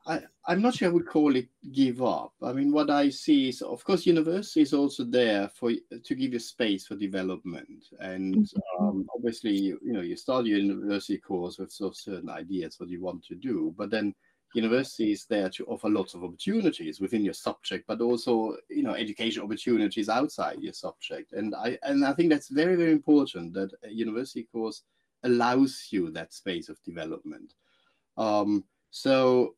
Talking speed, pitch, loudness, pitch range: 190 wpm, 125 Hz, -28 LUFS, 105-165 Hz